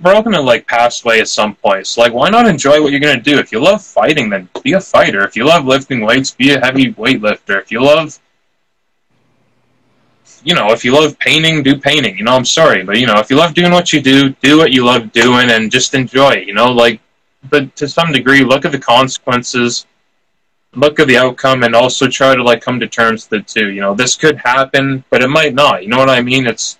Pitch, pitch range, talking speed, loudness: 130 Hz, 120-145 Hz, 245 wpm, -10 LUFS